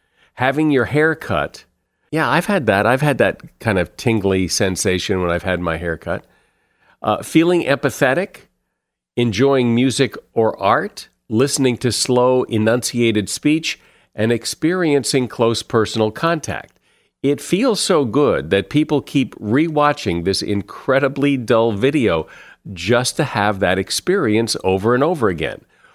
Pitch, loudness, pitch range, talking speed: 125 Hz, -18 LUFS, 105-145 Hz, 140 wpm